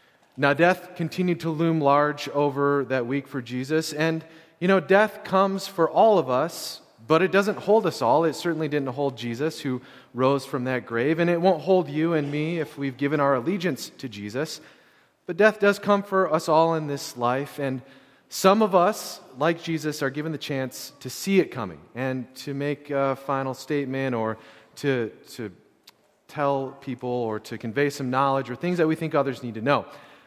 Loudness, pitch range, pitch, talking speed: -24 LUFS, 135-170 Hz, 145 Hz, 195 wpm